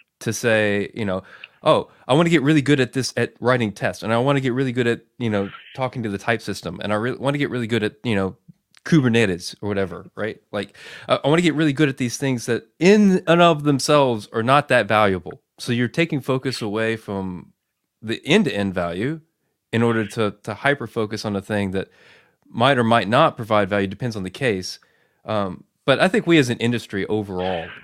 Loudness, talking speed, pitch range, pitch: -21 LUFS, 225 wpm, 105-140 Hz, 115 Hz